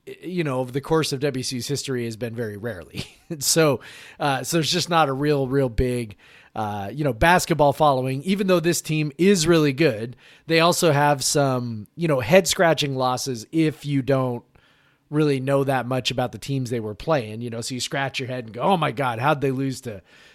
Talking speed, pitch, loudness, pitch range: 210 wpm, 140 Hz, -22 LUFS, 125-160 Hz